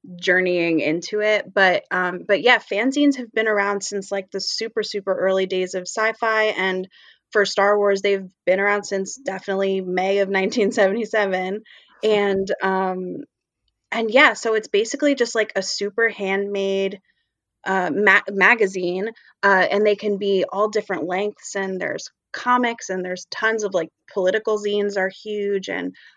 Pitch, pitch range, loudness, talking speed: 200 Hz, 190-215 Hz, -20 LUFS, 155 wpm